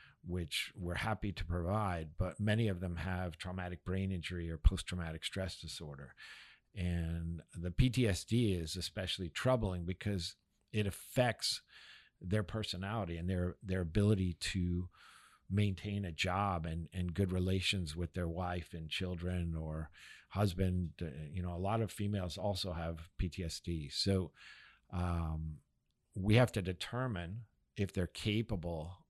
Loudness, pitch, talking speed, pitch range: -38 LUFS, 90 Hz, 135 wpm, 85-100 Hz